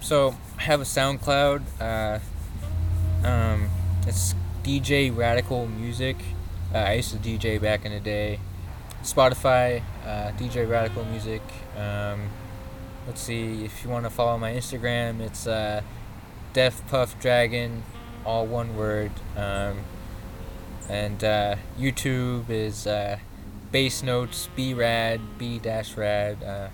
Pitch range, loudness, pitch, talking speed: 100-120 Hz, -26 LUFS, 110 Hz, 125 wpm